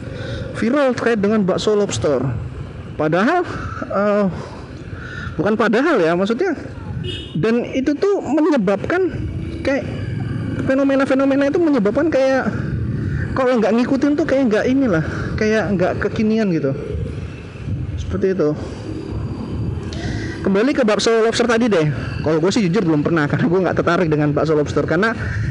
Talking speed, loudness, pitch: 125 wpm, -18 LUFS, 185 Hz